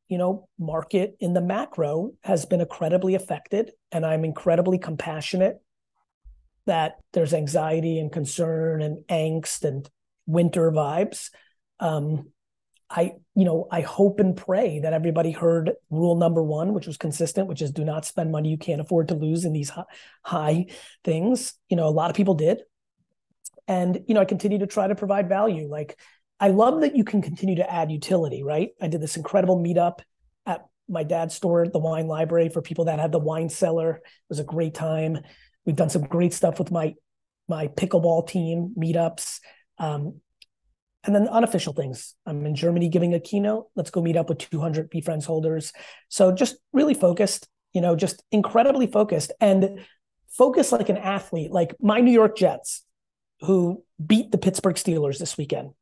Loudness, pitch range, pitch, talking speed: -24 LUFS, 160-190 Hz, 170 Hz, 175 wpm